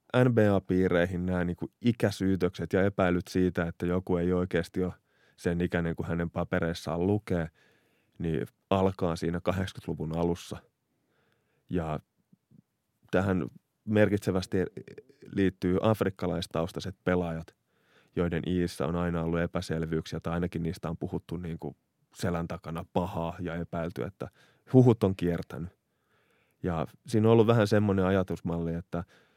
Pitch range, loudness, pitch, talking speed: 85-95 Hz, -30 LUFS, 90 Hz, 120 wpm